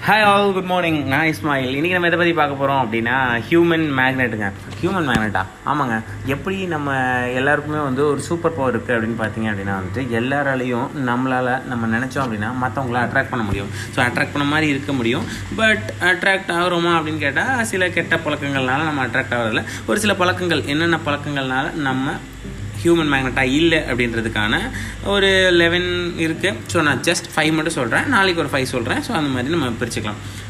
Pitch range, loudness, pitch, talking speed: 120-165 Hz, -19 LUFS, 135 Hz, 165 wpm